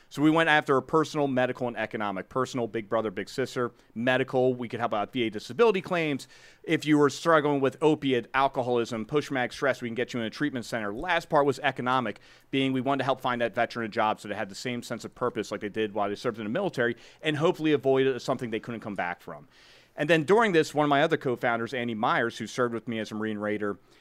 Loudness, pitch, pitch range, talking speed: -27 LUFS, 125 Hz, 115-140 Hz, 250 wpm